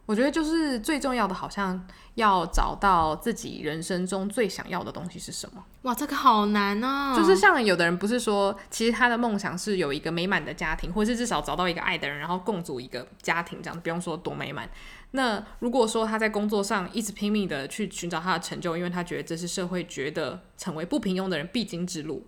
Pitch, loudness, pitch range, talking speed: 195 Hz, -27 LUFS, 175-225 Hz, 345 characters per minute